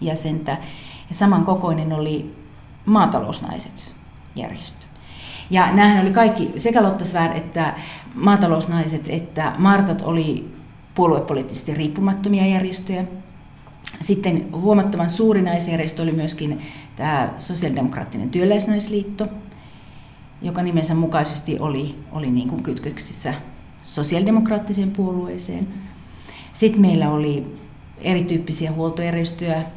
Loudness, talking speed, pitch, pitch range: -20 LUFS, 85 wpm, 170 Hz, 155-195 Hz